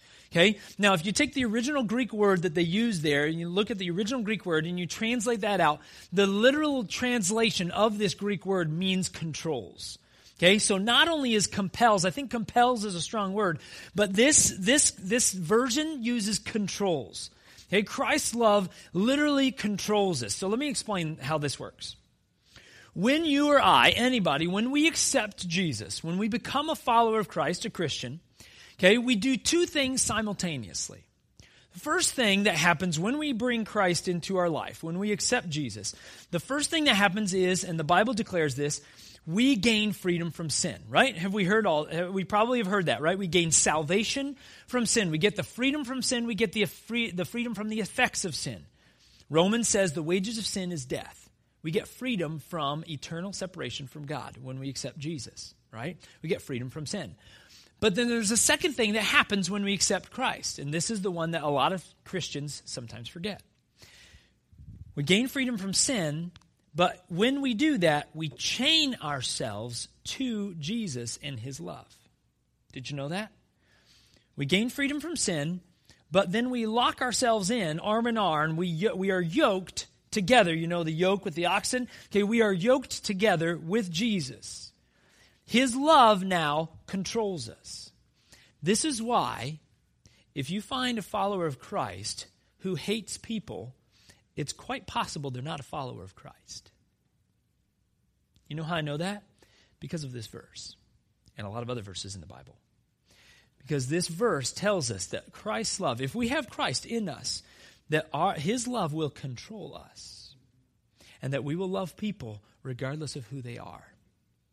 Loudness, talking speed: -27 LUFS, 180 wpm